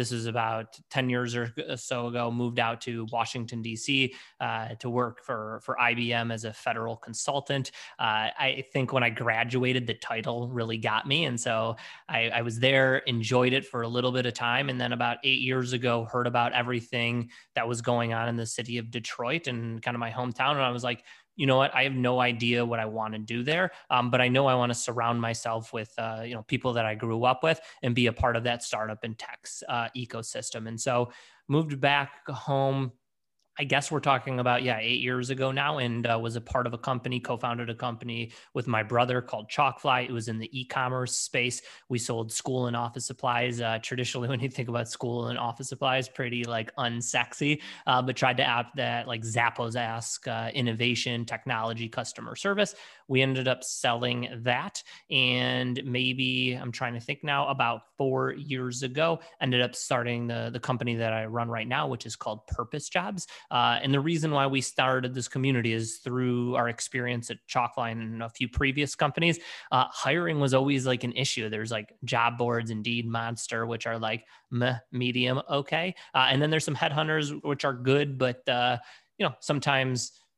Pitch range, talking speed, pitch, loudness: 115-130 Hz, 205 wpm, 125 Hz, -28 LUFS